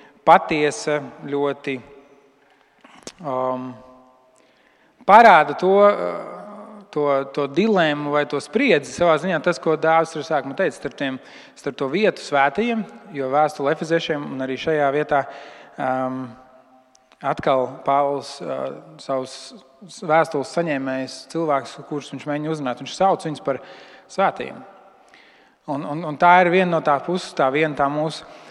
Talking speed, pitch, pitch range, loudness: 115 wpm, 145 Hz, 135-160 Hz, -20 LUFS